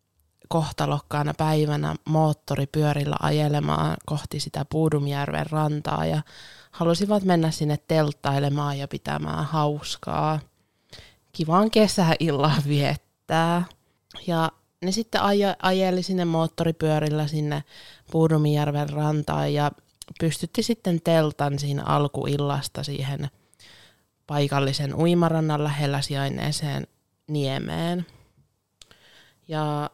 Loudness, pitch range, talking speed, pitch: -24 LUFS, 140-165 Hz, 80 wpm, 150 Hz